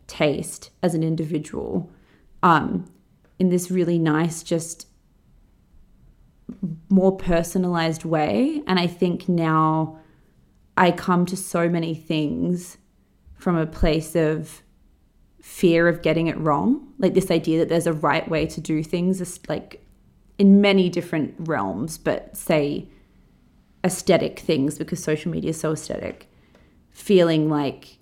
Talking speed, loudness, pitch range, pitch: 130 wpm, -22 LUFS, 155-180 Hz, 165 Hz